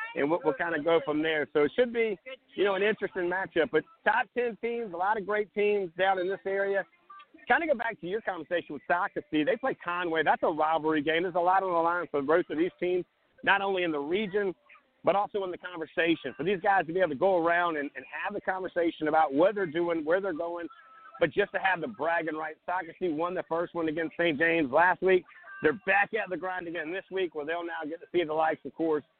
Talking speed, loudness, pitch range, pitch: 255 wpm, -29 LUFS, 160-195 Hz, 180 Hz